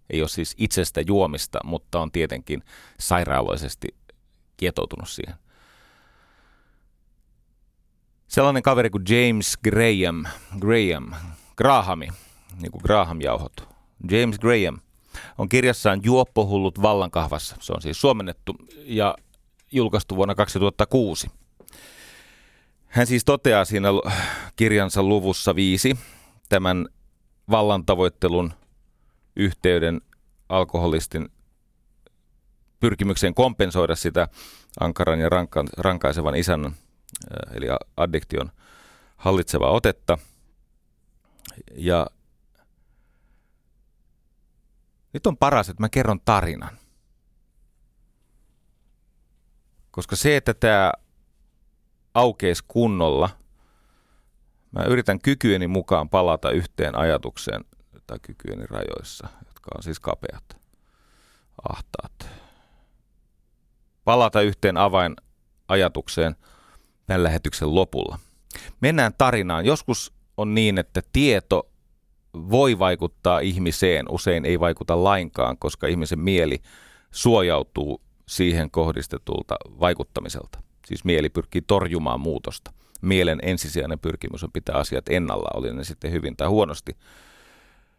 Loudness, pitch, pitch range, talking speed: -22 LUFS, 95 Hz, 80-105 Hz, 90 wpm